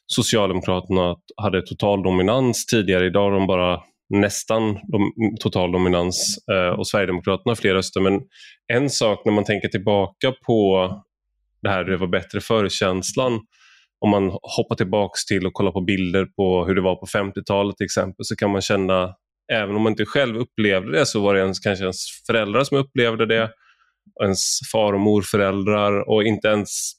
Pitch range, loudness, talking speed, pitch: 95-110 Hz, -20 LUFS, 165 wpm, 100 Hz